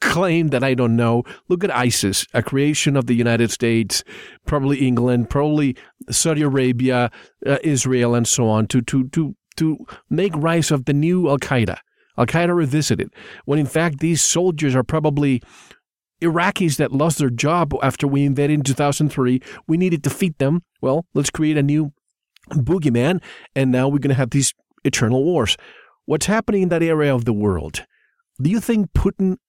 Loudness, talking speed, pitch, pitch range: -19 LUFS, 175 wpm, 145 Hz, 125-165 Hz